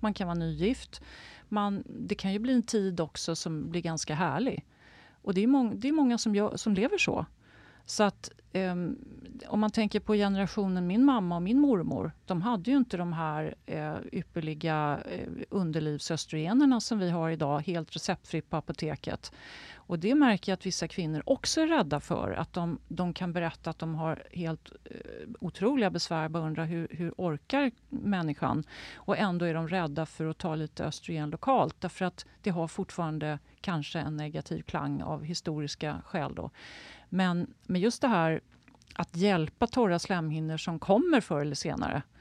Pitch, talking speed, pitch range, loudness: 175 Hz, 175 wpm, 160-210 Hz, -31 LUFS